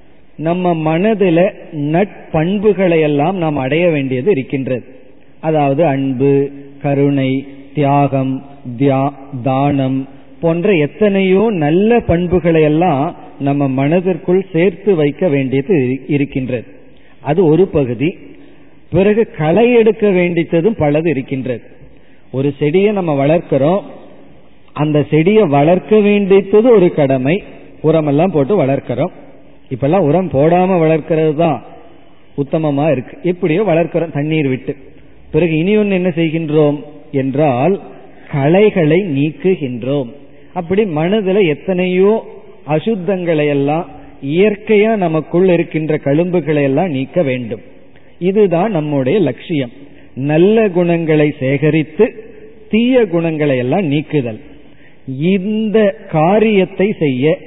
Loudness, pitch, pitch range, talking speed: -14 LUFS, 155 Hz, 140-185 Hz, 95 wpm